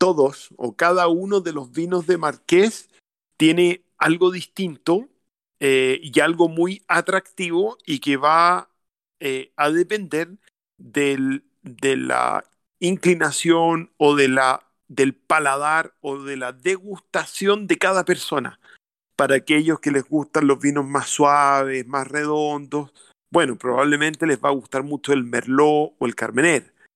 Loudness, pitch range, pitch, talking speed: -20 LUFS, 140-180 Hz, 150 Hz, 140 wpm